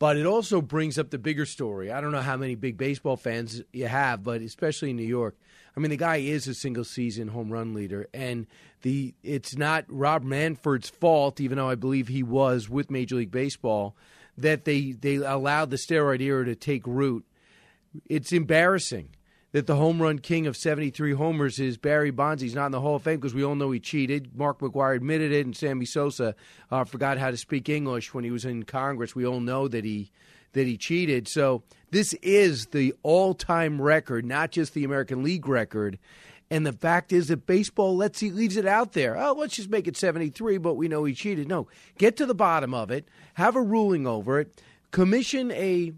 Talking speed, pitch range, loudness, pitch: 215 wpm, 130-160 Hz, -26 LUFS, 140 Hz